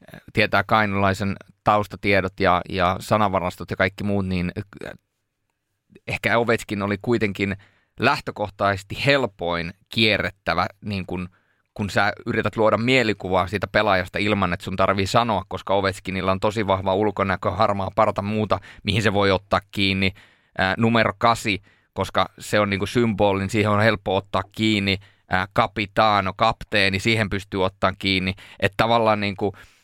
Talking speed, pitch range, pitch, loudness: 140 wpm, 95-110 Hz, 100 Hz, -22 LUFS